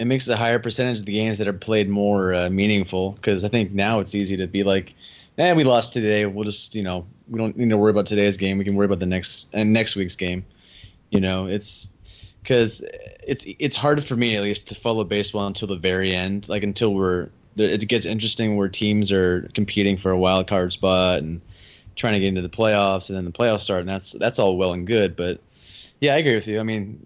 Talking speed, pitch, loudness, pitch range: 245 wpm, 100 Hz, -21 LUFS, 95-110 Hz